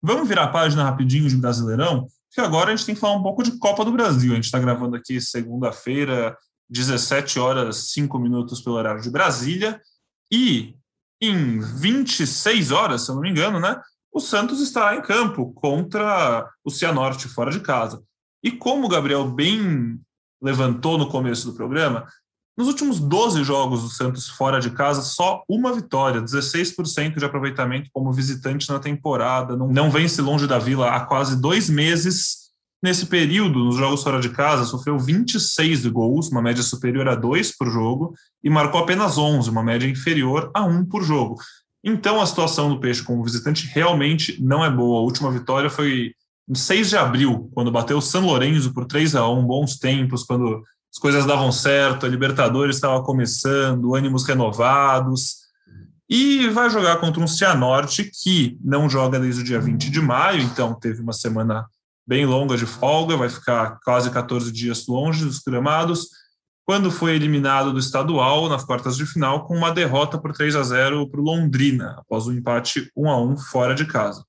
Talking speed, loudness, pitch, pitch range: 180 wpm, -20 LUFS, 140 Hz, 125-165 Hz